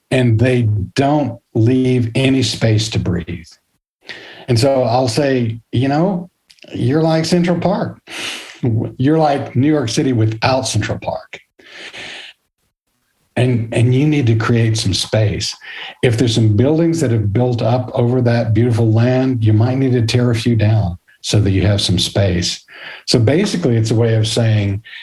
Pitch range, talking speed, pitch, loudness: 110-130 Hz, 160 wpm, 120 Hz, -15 LUFS